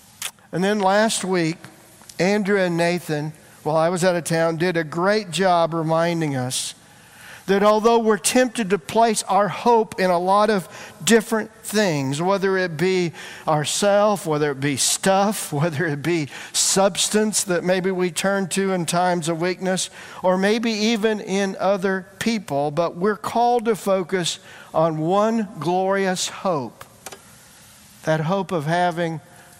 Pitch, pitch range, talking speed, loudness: 185 Hz, 165-205 Hz, 150 wpm, -21 LUFS